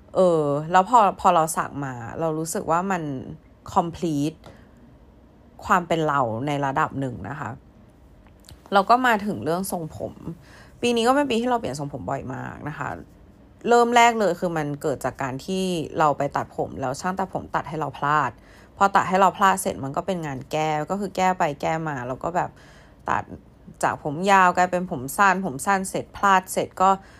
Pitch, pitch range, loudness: 165 Hz, 140-190 Hz, -23 LUFS